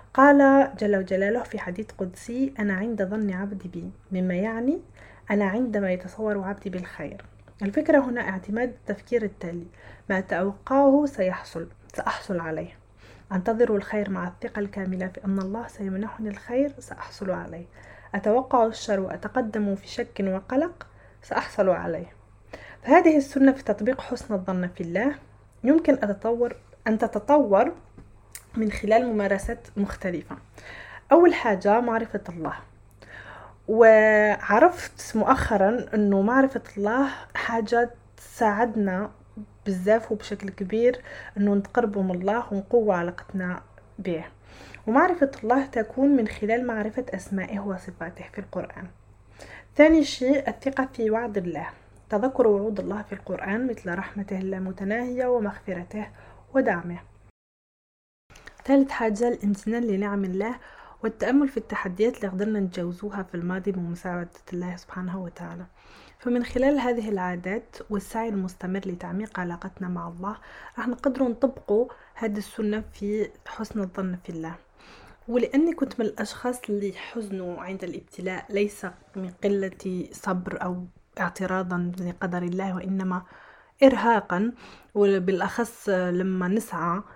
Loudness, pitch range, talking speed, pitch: -25 LUFS, 185-235 Hz, 115 wpm, 205 Hz